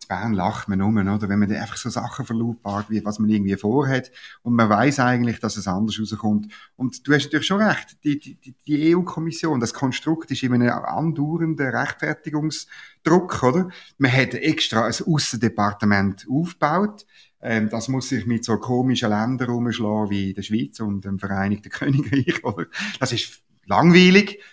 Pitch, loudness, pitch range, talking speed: 125 Hz, -21 LUFS, 105-150 Hz, 165 wpm